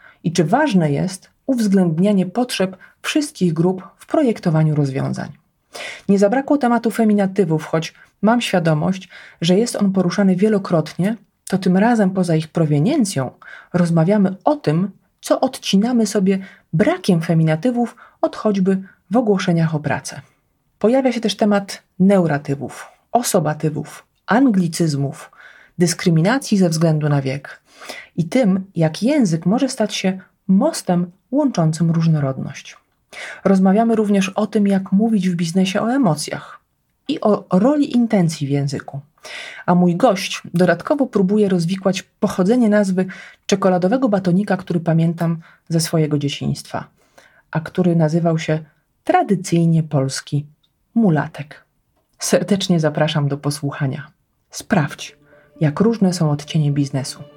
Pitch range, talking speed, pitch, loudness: 160-210 Hz, 120 wpm, 185 Hz, -18 LUFS